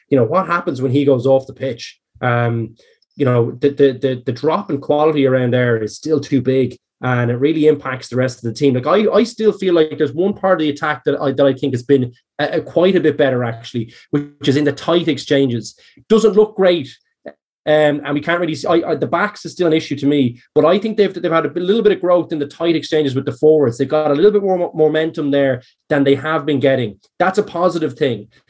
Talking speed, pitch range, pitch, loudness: 255 wpm, 135-170 Hz, 145 Hz, -16 LUFS